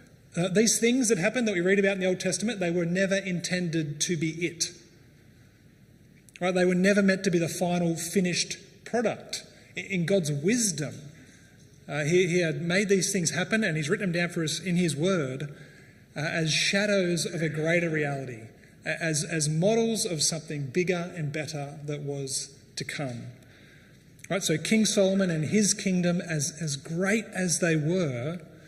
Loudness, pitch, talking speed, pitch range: -27 LUFS, 170 Hz, 180 wpm, 150-185 Hz